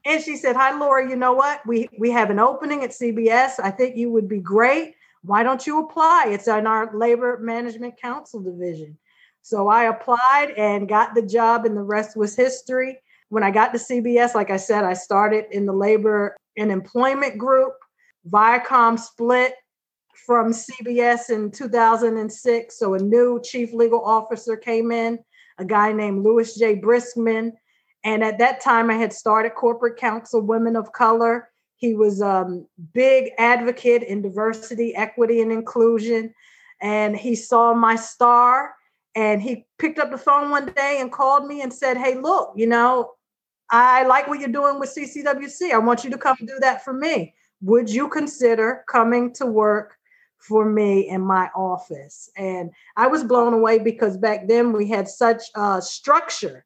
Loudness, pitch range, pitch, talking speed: -19 LUFS, 215-255 Hz, 230 Hz, 175 wpm